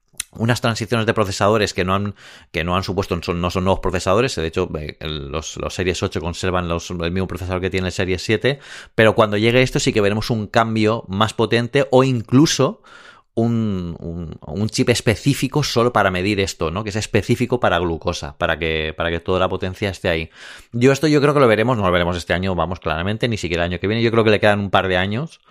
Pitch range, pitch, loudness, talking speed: 90-115 Hz, 100 Hz, -19 LUFS, 230 wpm